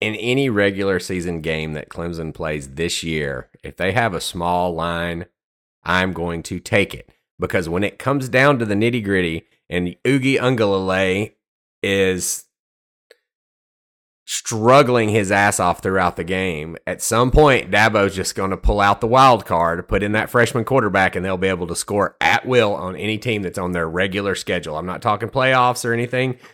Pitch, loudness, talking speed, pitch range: 95 Hz, -19 LUFS, 180 wpm, 85-115 Hz